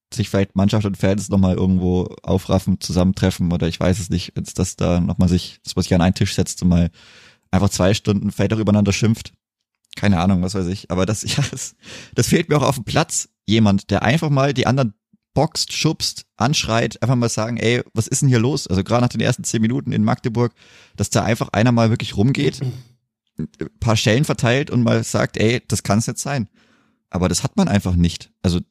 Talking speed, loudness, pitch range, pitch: 220 wpm, -19 LUFS, 95-120 Hz, 105 Hz